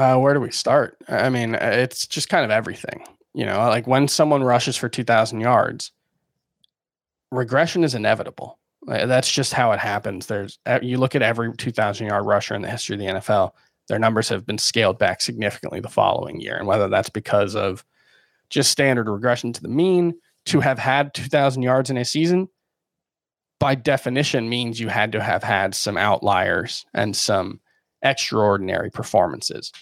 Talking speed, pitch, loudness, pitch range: 175 wpm, 125 Hz, -21 LUFS, 110-135 Hz